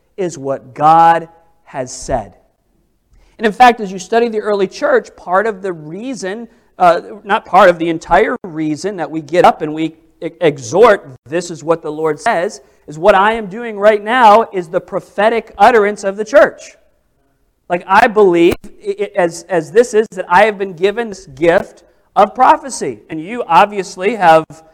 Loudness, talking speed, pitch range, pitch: -13 LUFS, 180 wpm, 165-215 Hz, 190 Hz